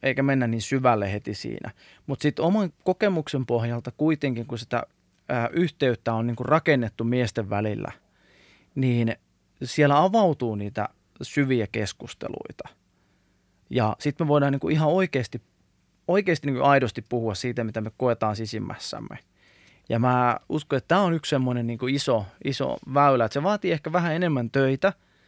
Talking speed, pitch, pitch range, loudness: 145 wpm, 125 Hz, 115-145 Hz, -25 LUFS